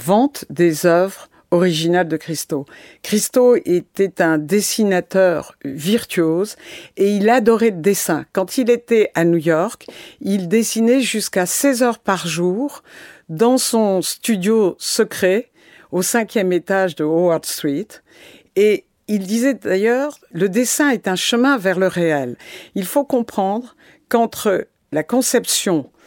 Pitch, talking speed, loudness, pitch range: 200 Hz, 130 wpm, -17 LUFS, 175-235 Hz